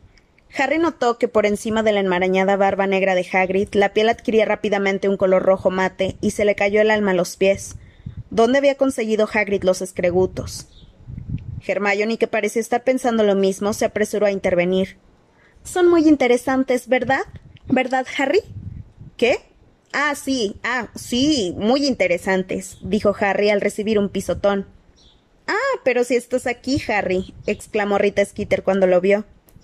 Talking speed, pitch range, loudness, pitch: 155 wpm, 190-245 Hz, -19 LUFS, 205 Hz